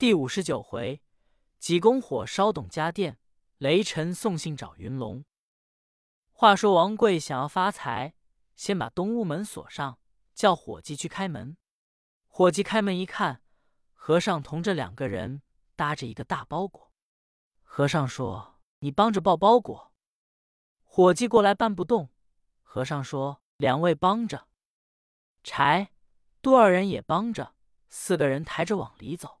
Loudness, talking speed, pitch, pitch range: -26 LUFS, 200 characters per minute, 175 Hz, 140-200 Hz